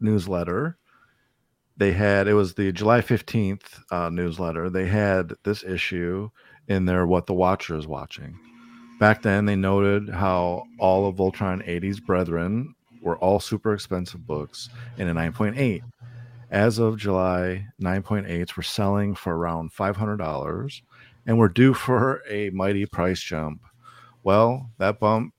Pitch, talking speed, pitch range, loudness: 100 Hz, 140 wpm, 90-110 Hz, -24 LUFS